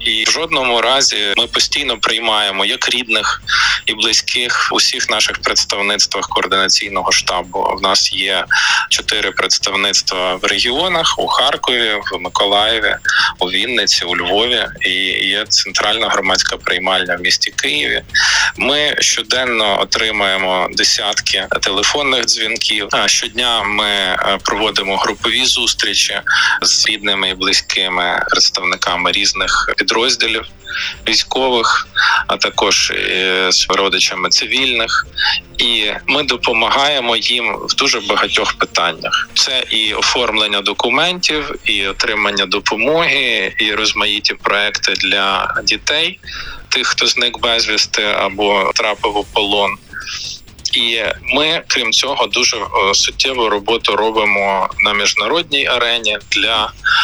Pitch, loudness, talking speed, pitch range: 110 Hz, -13 LUFS, 110 wpm, 100-150 Hz